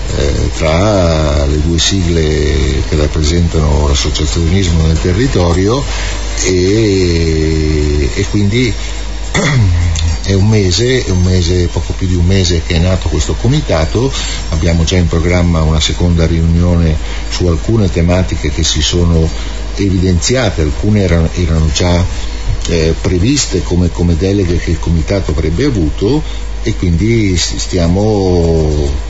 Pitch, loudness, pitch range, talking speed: 85 Hz, -12 LUFS, 80-95 Hz, 120 wpm